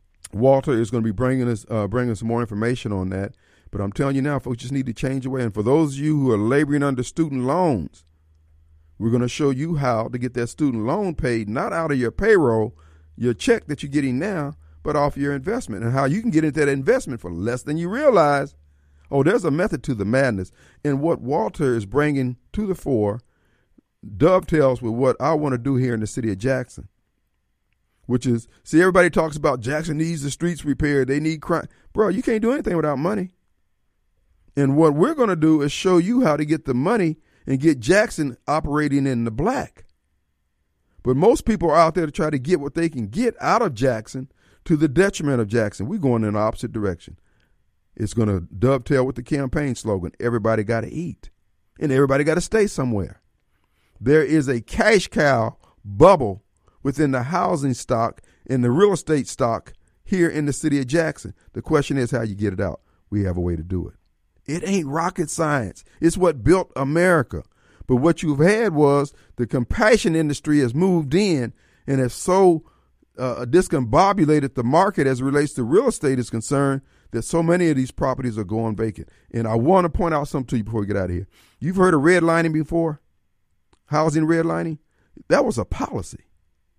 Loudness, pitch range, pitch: -21 LUFS, 110-160 Hz, 135 Hz